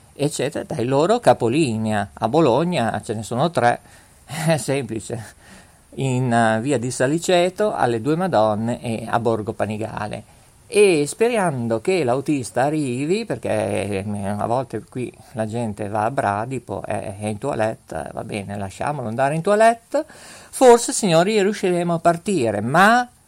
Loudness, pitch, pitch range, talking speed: -20 LUFS, 120 Hz, 110-170 Hz, 135 wpm